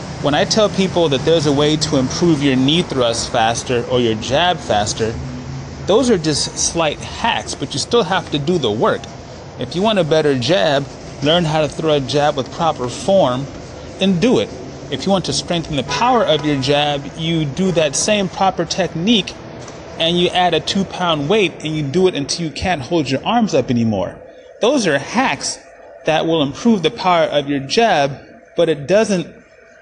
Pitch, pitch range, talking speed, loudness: 160 Hz, 140-180 Hz, 195 wpm, -16 LUFS